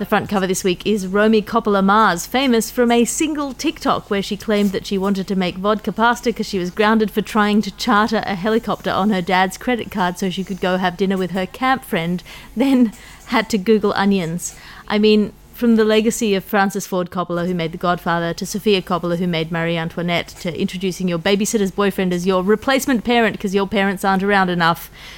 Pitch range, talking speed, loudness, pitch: 185-220 Hz, 210 wpm, -18 LUFS, 200 Hz